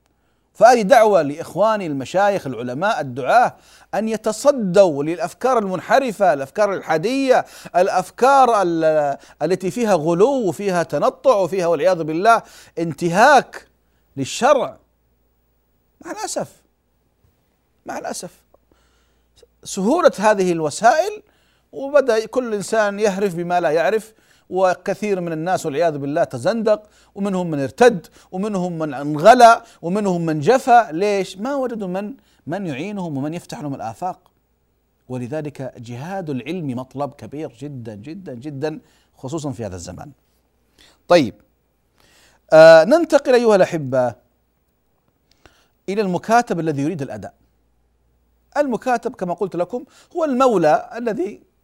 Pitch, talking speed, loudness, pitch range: 175 Hz, 105 wpm, -18 LUFS, 135-215 Hz